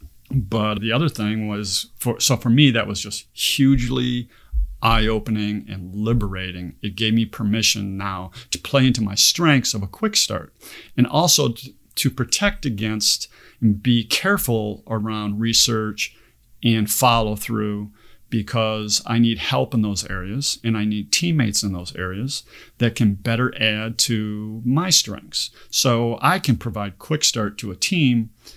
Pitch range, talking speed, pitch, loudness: 105-125 Hz, 155 wpm, 110 Hz, -20 LUFS